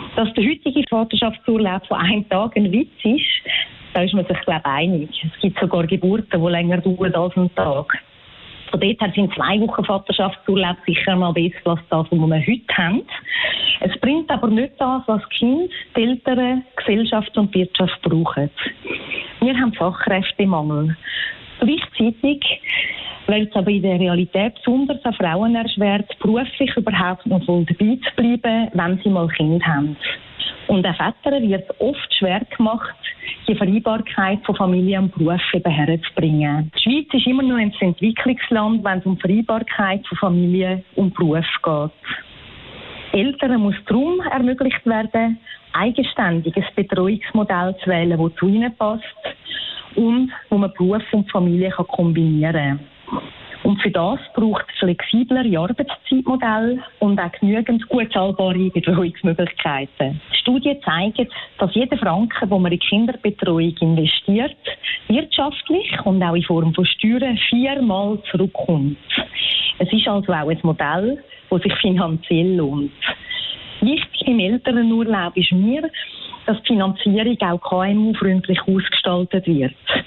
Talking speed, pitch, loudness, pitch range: 145 wpm, 200 Hz, -19 LUFS, 180-235 Hz